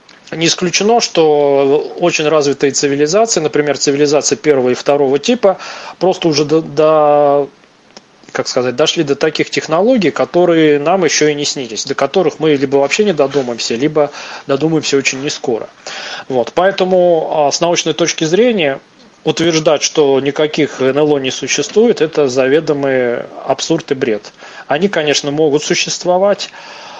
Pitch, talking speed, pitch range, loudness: 150 Hz, 135 wpm, 140-165 Hz, -13 LUFS